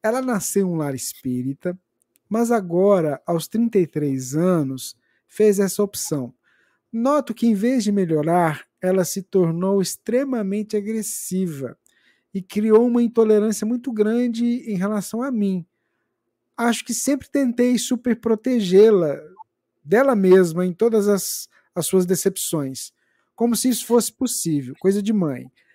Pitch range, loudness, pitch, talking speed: 180-235 Hz, -20 LUFS, 205 Hz, 135 wpm